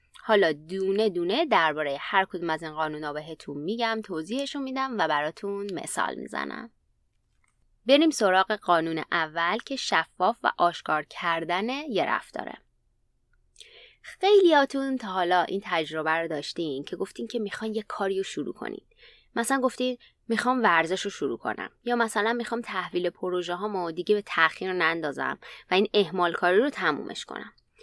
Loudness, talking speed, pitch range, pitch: -26 LUFS, 150 wpm, 170-240 Hz, 195 Hz